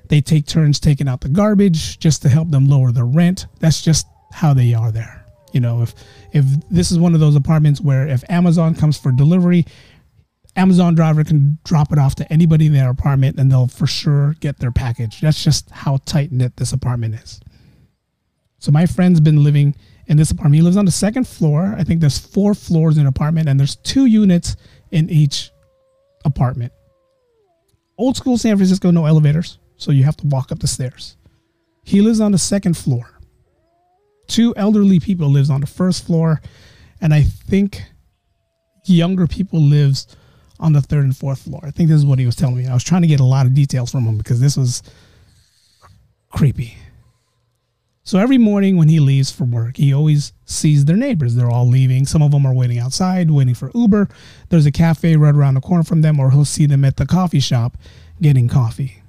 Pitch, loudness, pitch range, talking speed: 145 Hz, -15 LUFS, 130-170 Hz, 200 wpm